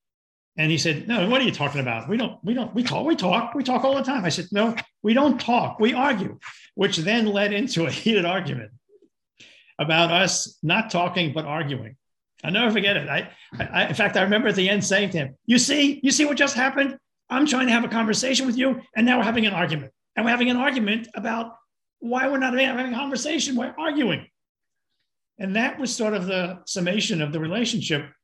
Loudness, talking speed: -22 LUFS, 220 wpm